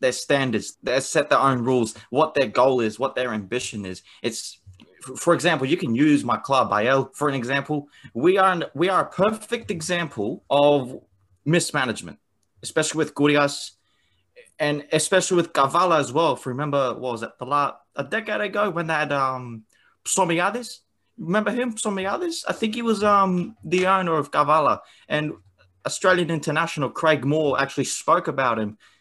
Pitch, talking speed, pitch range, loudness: 150 Hz, 170 wpm, 125-185 Hz, -22 LUFS